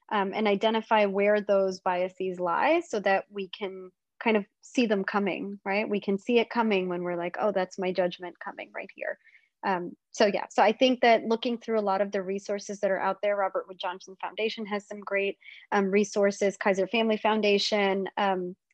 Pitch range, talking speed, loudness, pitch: 190-215 Hz, 200 wpm, -27 LUFS, 200 Hz